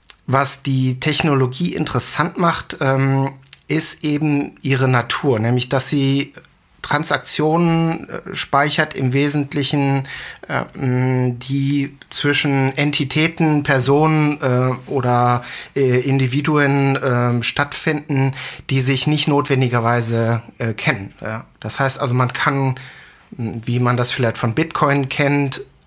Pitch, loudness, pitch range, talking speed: 135 Hz, -18 LUFS, 130-145 Hz, 95 wpm